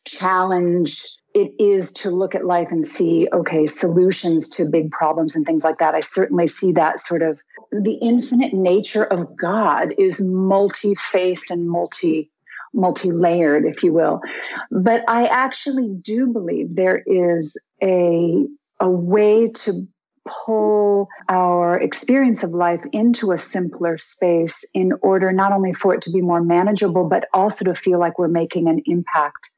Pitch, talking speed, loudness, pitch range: 185 Hz, 155 wpm, -18 LUFS, 170-205 Hz